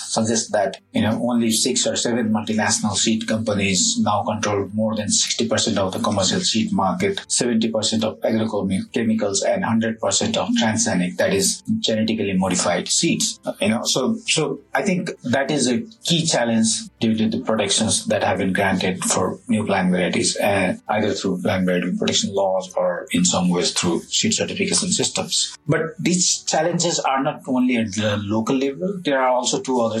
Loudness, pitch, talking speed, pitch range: -20 LUFS, 115 Hz, 170 wpm, 105-160 Hz